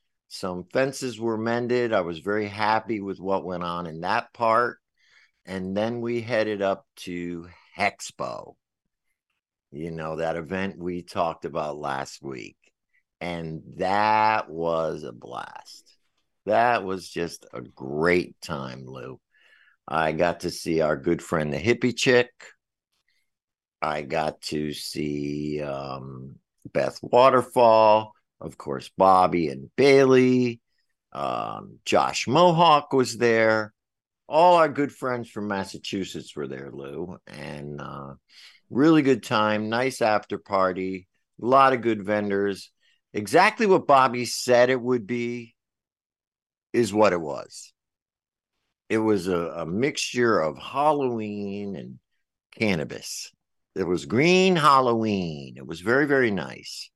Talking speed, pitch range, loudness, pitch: 125 wpm, 85-120 Hz, -23 LUFS, 105 Hz